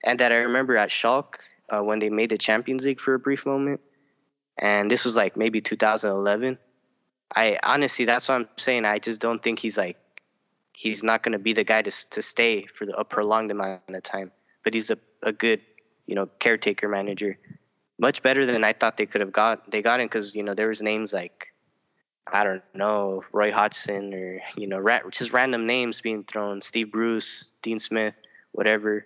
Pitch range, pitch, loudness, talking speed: 105-120 Hz, 110 Hz, -24 LUFS, 205 wpm